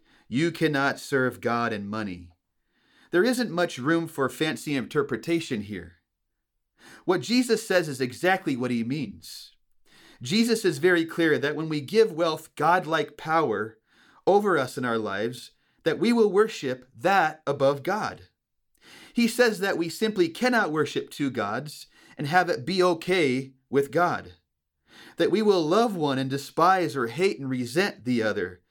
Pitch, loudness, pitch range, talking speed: 155 Hz, -25 LUFS, 125-180 Hz, 155 wpm